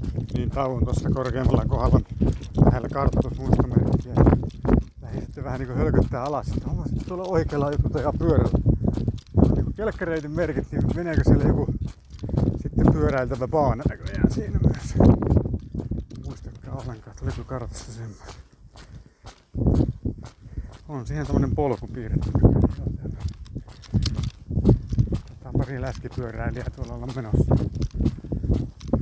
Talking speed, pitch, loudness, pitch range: 110 wpm, 125 Hz, -24 LUFS, 110-135 Hz